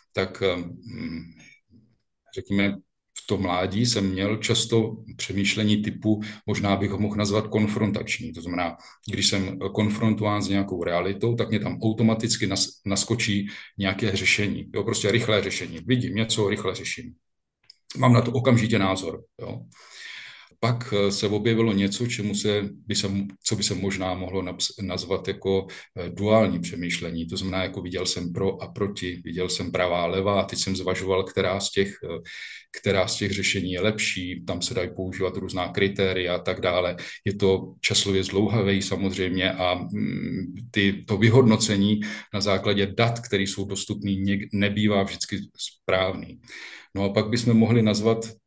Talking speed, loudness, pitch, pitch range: 150 wpm, -24 LUFS, 100 Hz, 95-110 Hz